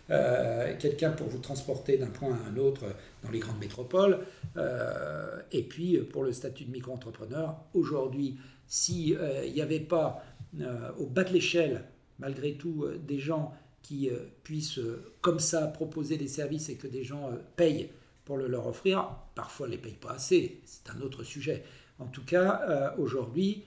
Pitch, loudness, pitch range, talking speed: 140 Hz, -32 LUFS, 130-160 Hz, 190 wpm